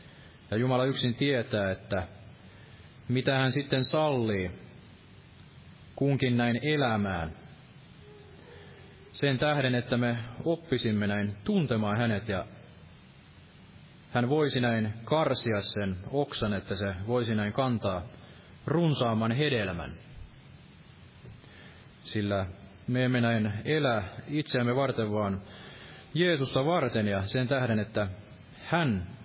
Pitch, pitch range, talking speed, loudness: 120 Hz, 105-135 Hz, 100 wpm, -29 LUFS